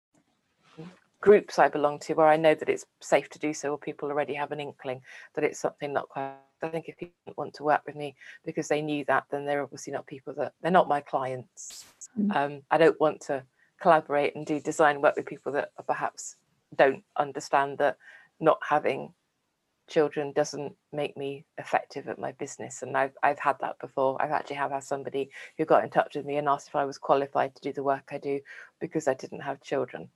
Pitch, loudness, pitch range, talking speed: 145 Hz, -28 LUFS, 140-155 Hz, 215 wpm